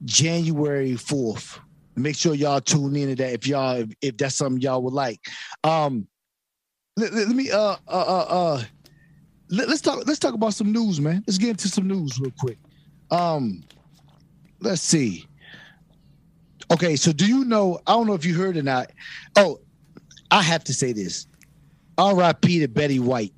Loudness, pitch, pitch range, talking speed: -22 LUFS, 160 Hz, 140-180 Hz, 170 wpm